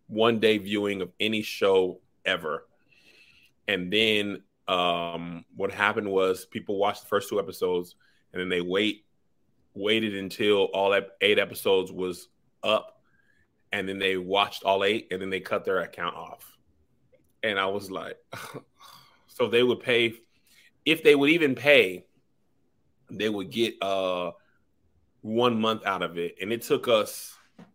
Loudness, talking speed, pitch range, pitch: -26 LUFS, 150 wpm, 90-110 Hz, 100 Hz